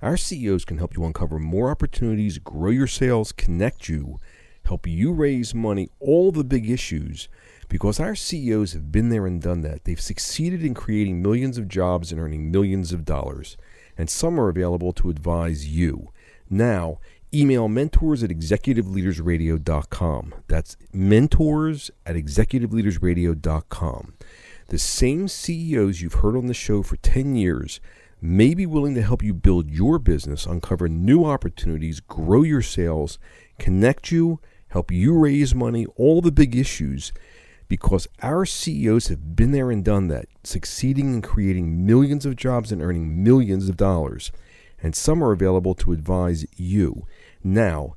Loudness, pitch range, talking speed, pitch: -22 LUFS, 85-125 Hz, 155 wpm, 95 Hz